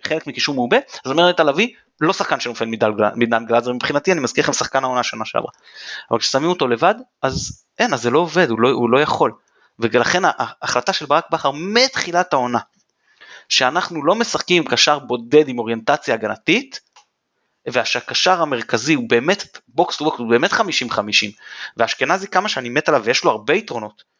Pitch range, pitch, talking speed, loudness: 120-165 Hz, 145 Hz, 175 wpm, -18 LUFS